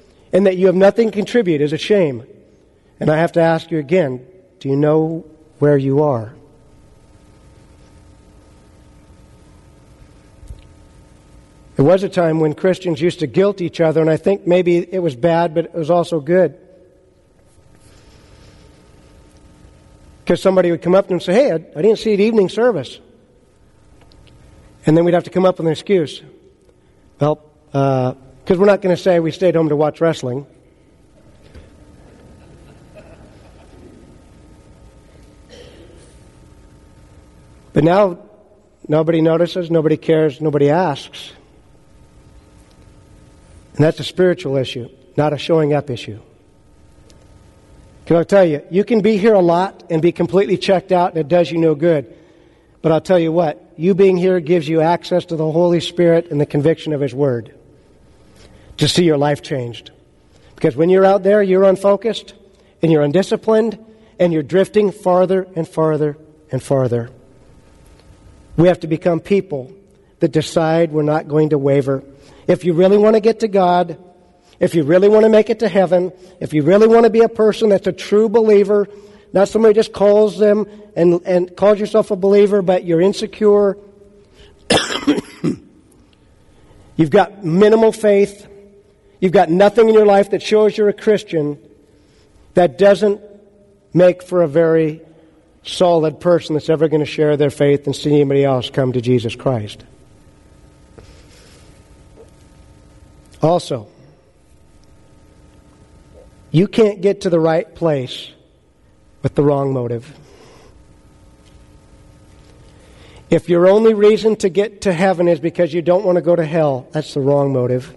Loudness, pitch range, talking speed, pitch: -15 LUFS, 145-195 Hz, 150 wpm, 170 Hz